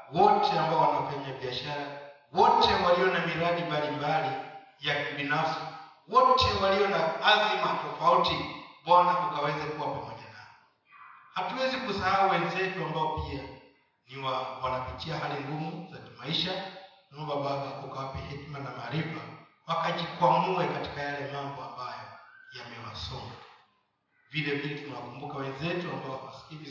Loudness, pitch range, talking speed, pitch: -29 LUFS, 145-185 Hz, 115 wpm, 155 Hz